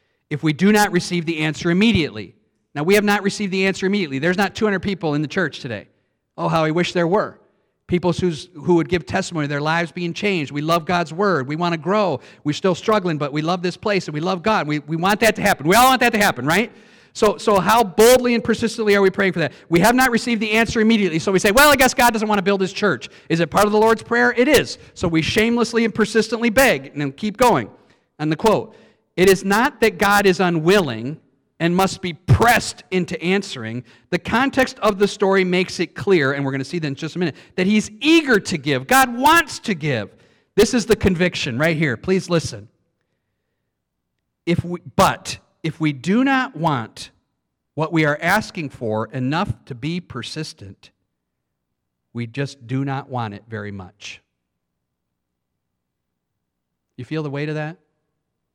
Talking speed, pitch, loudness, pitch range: 210 wpm, 175 Hz, -18 LUFS, 145-210 Hz